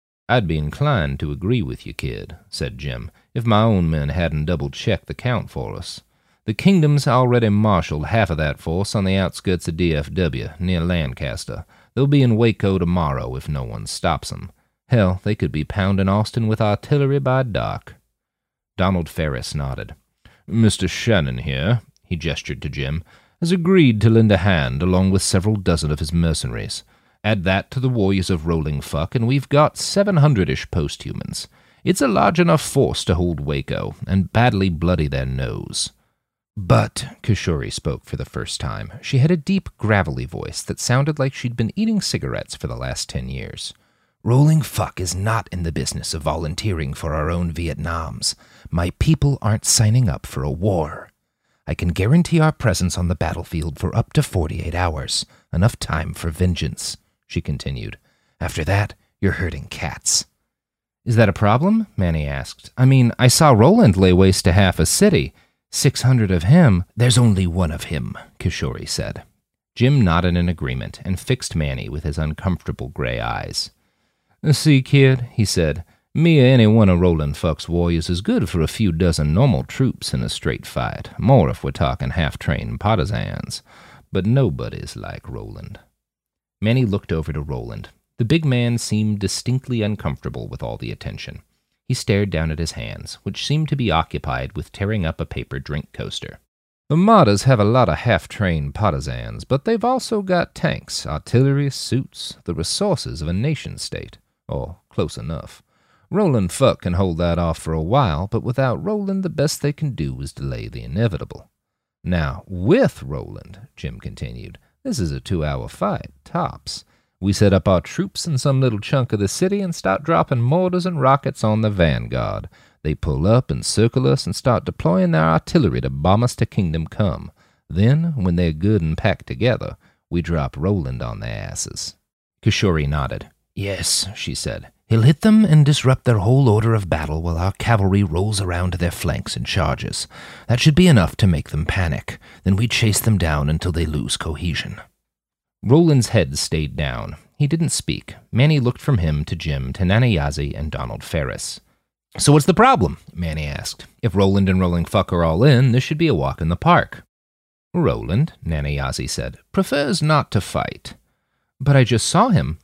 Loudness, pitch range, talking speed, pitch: -19 LUFS, 80-125 Hz, 180 wpm, 95 Hz